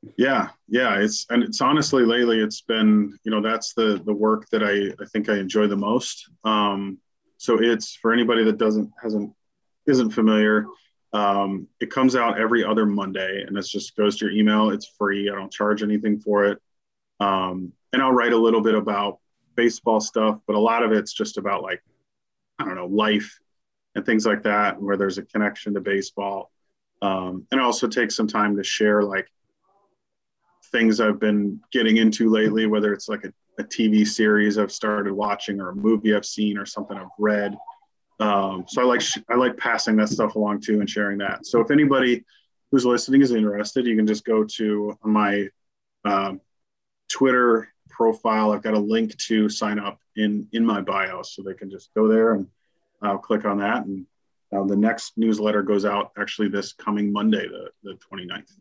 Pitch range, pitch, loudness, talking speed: 100-110 Hz, 105 Hz, -22 LUFS, 195 wpm